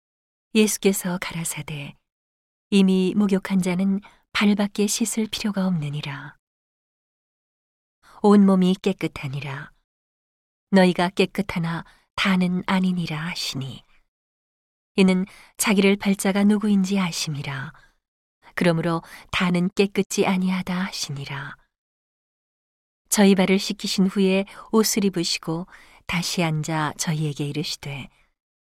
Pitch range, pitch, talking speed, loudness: 155-195 Hz, 185 Hz, 235 characters per minute, -22 LUFS